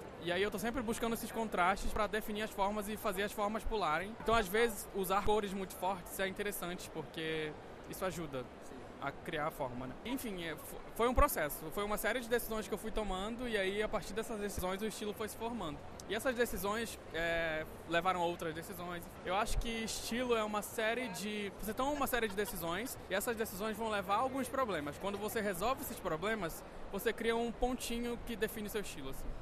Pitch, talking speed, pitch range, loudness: 215 Hz, 210 wpm, 190-230 Hz, -38 LUFS